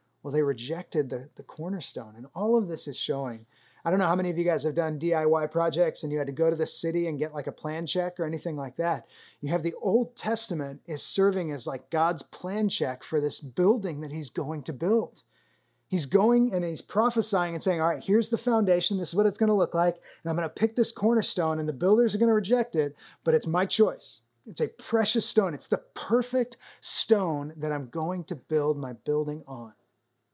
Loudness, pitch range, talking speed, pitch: -27 LUFS, 150-200 Hz, 230 wpm, 170 Hz